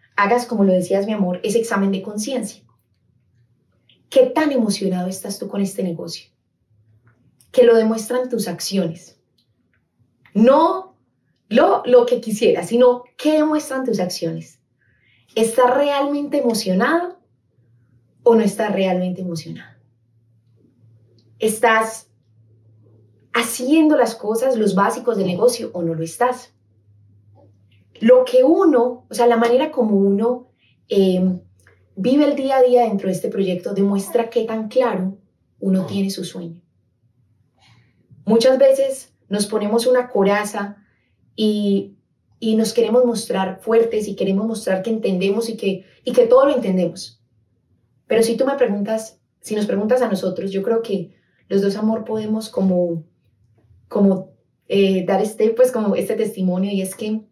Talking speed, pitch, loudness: 140 wpm, 200 Hz, -18 LUFS